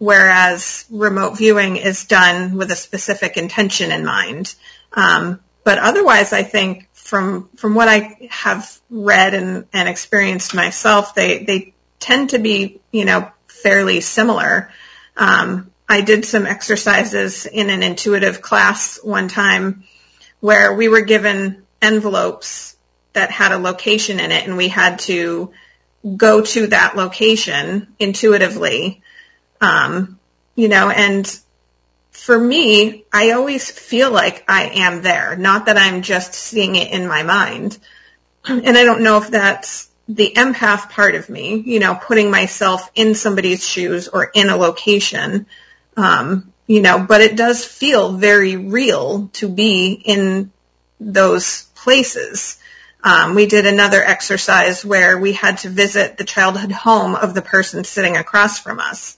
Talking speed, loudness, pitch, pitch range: 145 wpm, -13 LUFS, 200 Hz, 190-215 Hz